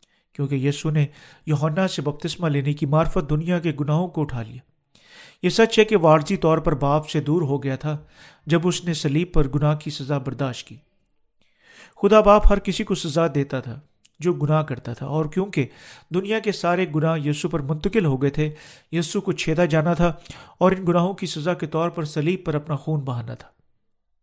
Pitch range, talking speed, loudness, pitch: 145-175 Hz, 200 wpm, -22 LUFS, 160 Hz